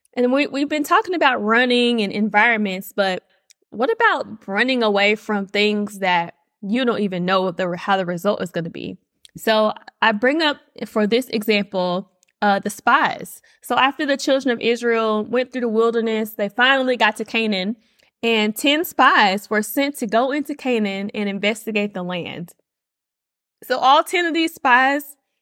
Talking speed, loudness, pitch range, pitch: 170 wpm, -19 LUFS, 200-255 Hz, 225 Hz